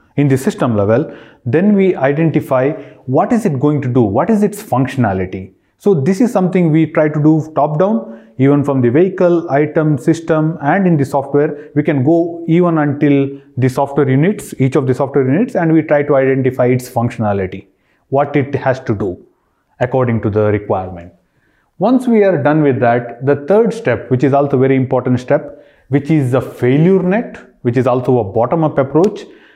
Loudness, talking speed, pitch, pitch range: -14 LUFS, 190 wpm, 145 Hz, 130-165 Hz